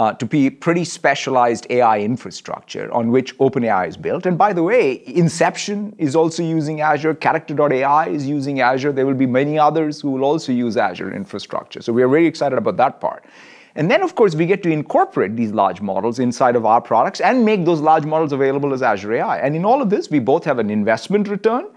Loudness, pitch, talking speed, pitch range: -17 LUFS, 150 Hz, 220 wpm, 130-170 Hz